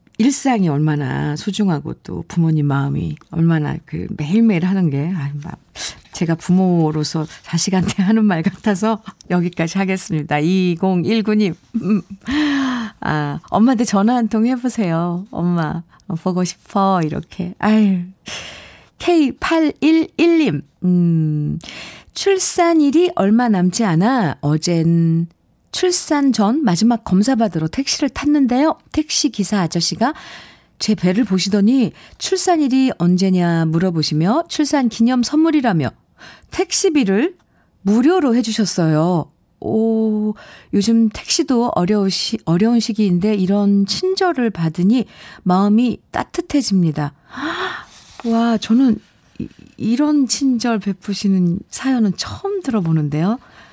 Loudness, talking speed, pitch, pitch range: -17 LUFS, 240 characters per minute, 205 Hz, 175-255 Hz